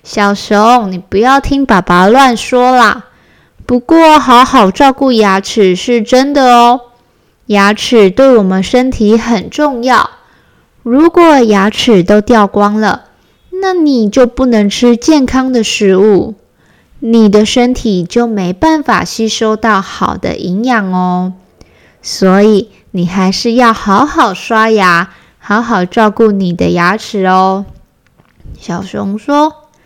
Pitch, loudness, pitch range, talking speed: 225 Hz, -9 LUFS, 200-255 Hz, 180 characters per minute